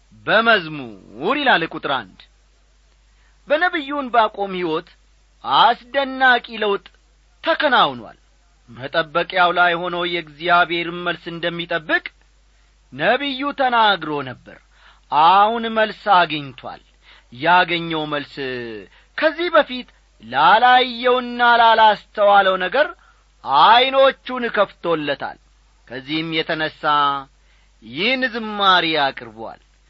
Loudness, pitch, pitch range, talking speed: -17 LUFS, 180 Hz, 155-250 Hz, 70 wpm